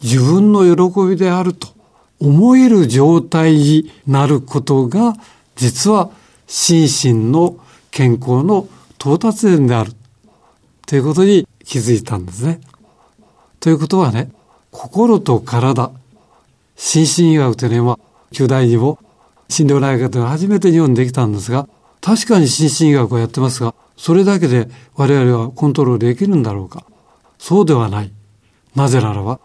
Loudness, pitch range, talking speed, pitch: -13 LUFS, 120-170 Hz, 280 characters per minute, 140 Hz